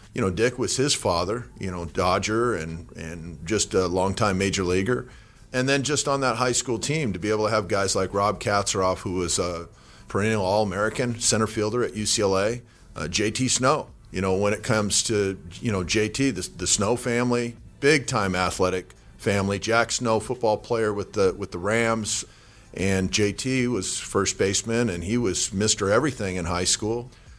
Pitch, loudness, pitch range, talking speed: 105 Hz, -24 LUFS, 95-120 Hz, 185 wpm